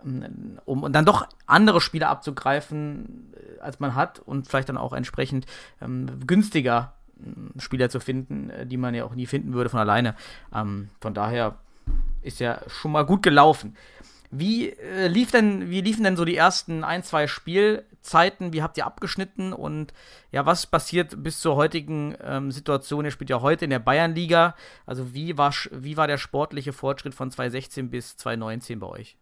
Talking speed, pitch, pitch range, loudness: 175 wpm, 145 Hz, 125-165 Hz, -24 LUFS